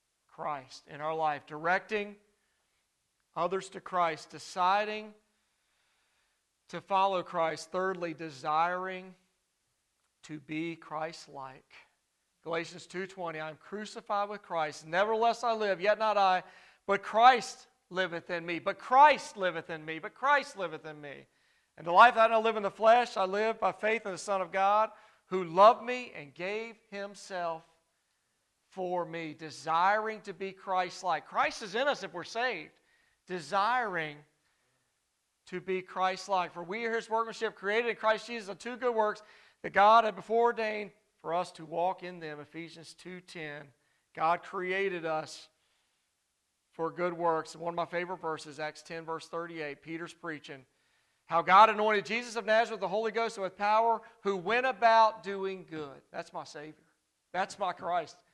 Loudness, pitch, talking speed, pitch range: -30 LUFS, 185 Hz, 160 wpm, 165-215 Hz